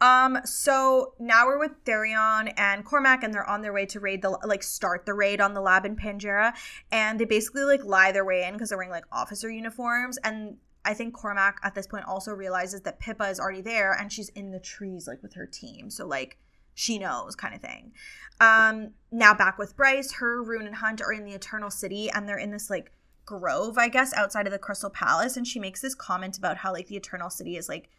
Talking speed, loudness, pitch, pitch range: 235 wpm, -25 LUFS, 210 Hz, 195-235 Hz